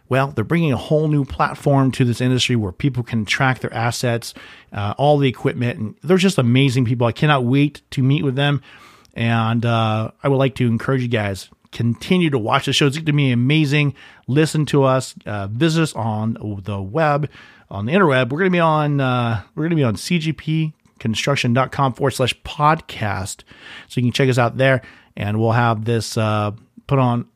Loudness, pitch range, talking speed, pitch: -19 LUFS, 115-145 Hz, 200 wpm, 130 Hz